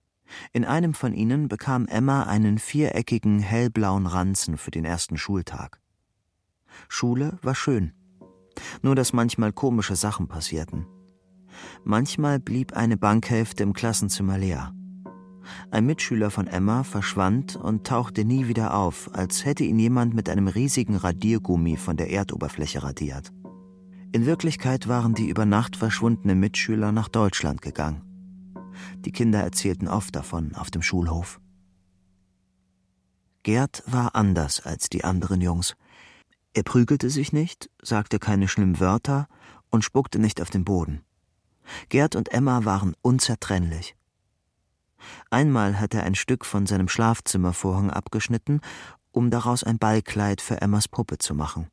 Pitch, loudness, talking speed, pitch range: 105 Hz, -24 LUFS, 135 wpm, 95-120 Hz